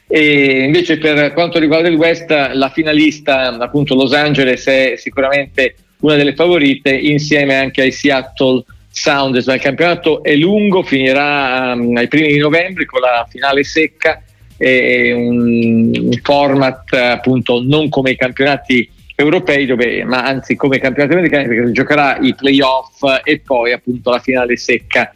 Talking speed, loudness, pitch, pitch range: 155 wpm, -12 LUFS, 135 Hz, 125-150 Hz